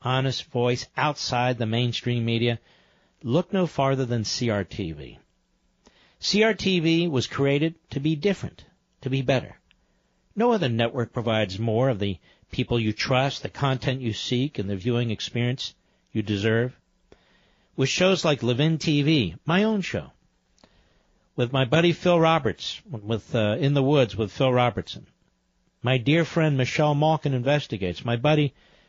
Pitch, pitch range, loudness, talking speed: 130 Hz, 115-150 Hz, -24 LUFS, 145 wpm